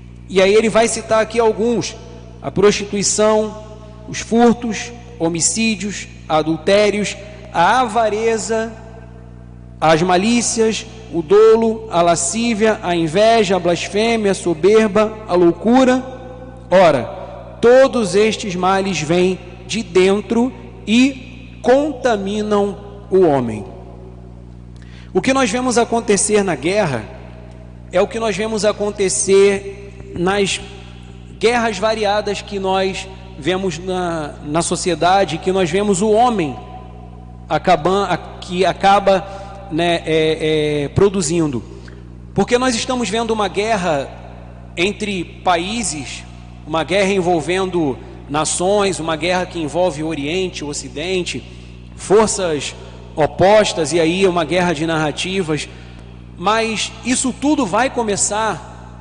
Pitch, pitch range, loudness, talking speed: 185 Hz, 145-215 Hz, -16 LUFS, 110 wpm